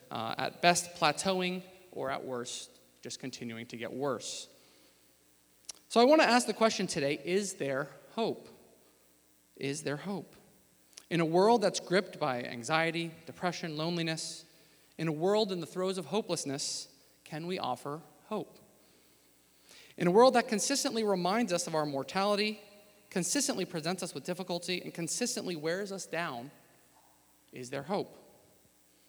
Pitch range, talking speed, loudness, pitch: 135-190 Hz, 145 wpm, -32 LUFS, 170 Hz